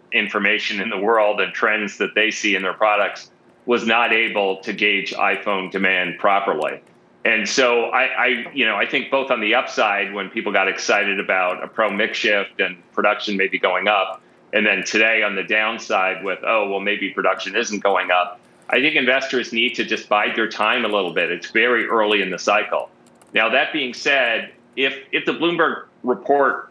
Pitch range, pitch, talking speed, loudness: 95-120 Hz, 105 Hz, 195 wpm, -19 LUFS